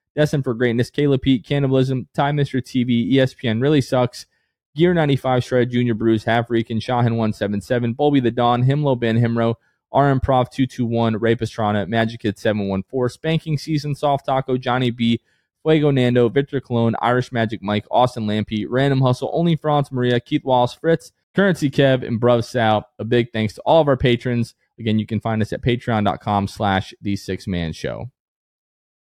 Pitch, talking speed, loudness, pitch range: 120 Hz, 170 wpm, -19 LUFS, 115-135 Hz